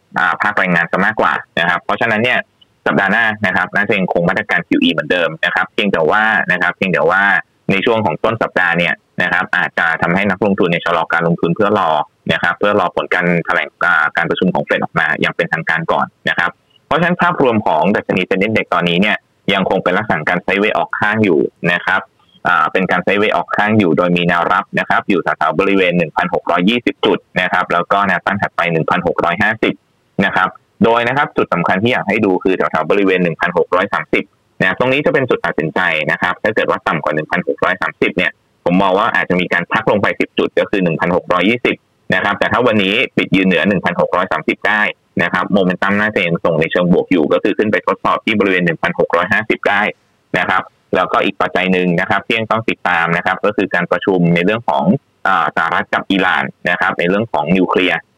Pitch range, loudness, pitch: 85-110 Hz, -14 LUFS, 95 Hz